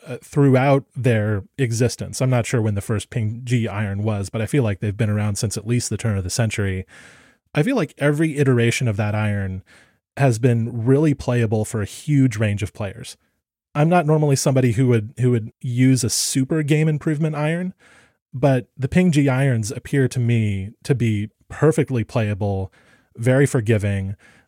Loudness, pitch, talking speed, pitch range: -20 LUFS, 120 Hz, 180 wpm, 110-140 Hz